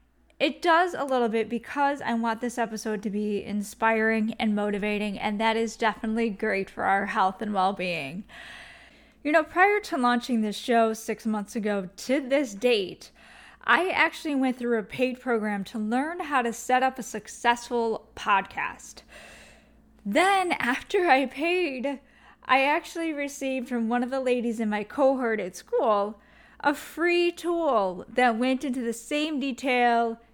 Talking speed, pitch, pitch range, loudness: 160 wpm, 240 Hz, 220-275 Hz, -26 LUFS